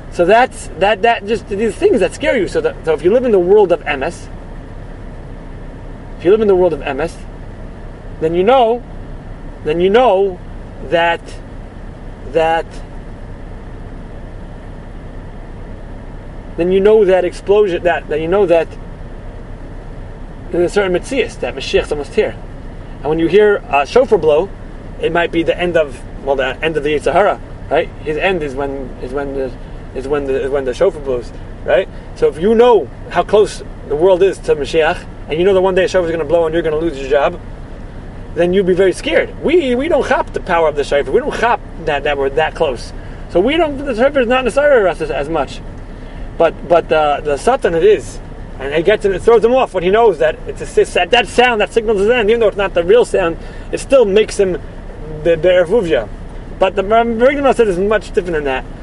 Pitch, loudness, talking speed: 170 Hz, -14 LUFS, 205 wpm